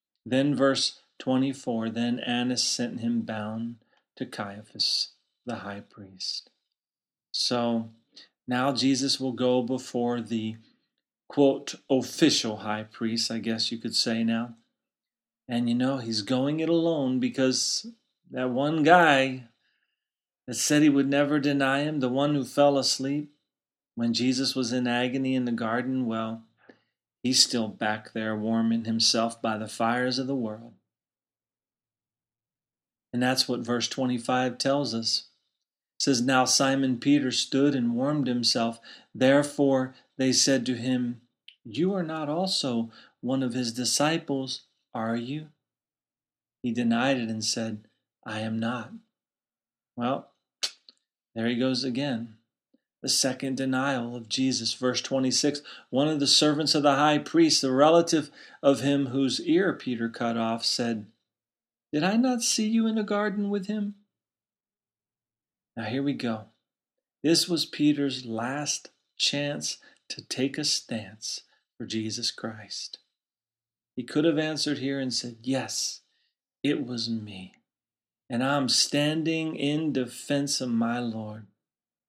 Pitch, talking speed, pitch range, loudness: 125 Hz, 140 wpm, 115-140 Hz, -26 LUFS